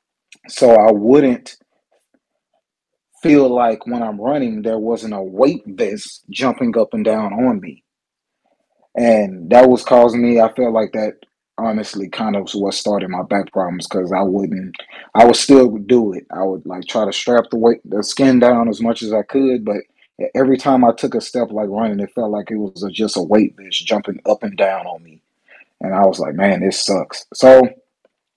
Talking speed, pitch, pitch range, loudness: 200 wpm, 110 Hz, 100-125 Hz, -15 LUFS